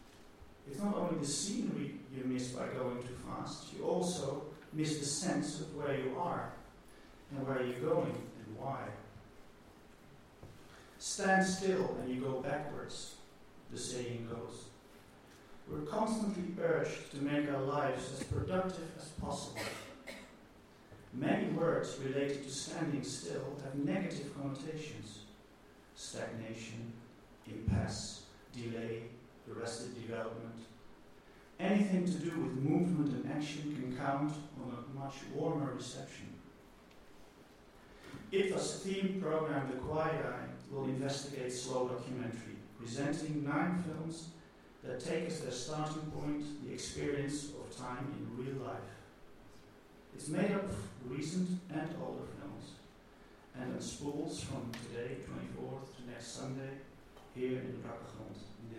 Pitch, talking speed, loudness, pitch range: 135 Hz, 125 wpm, -39 LUFS, 115-155 Hz